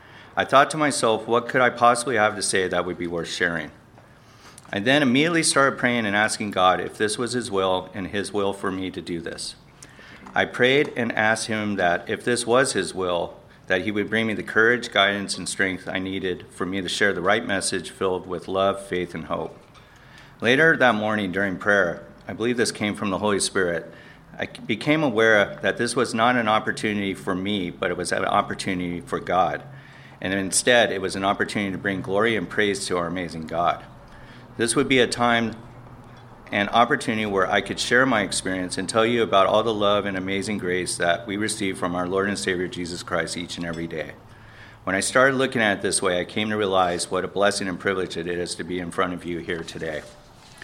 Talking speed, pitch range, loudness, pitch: 215 wpm, 90-115 Hz, -23 LUFS, 100 Hz